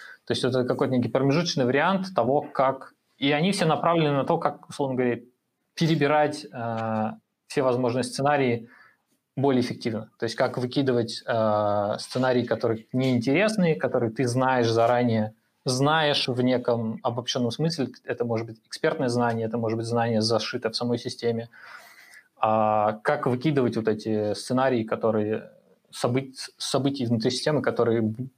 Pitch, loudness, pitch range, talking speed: 125 Hz, -25 LUFS, 115-140 Hz, 140 wpm